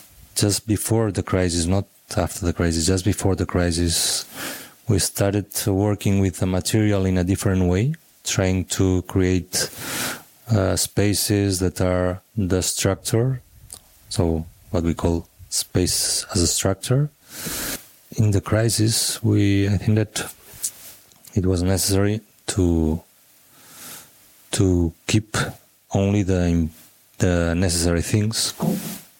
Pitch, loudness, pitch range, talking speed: 95 Hz, -21 LUFS, 90-110 Hz, 115 wpm